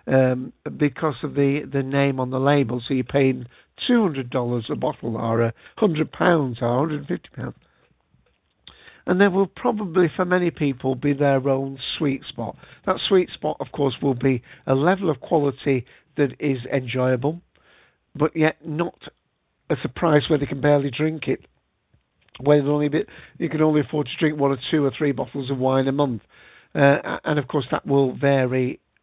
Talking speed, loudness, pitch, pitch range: 185 wpm, -22 LUFS, 140 Hz, 135-155 Hz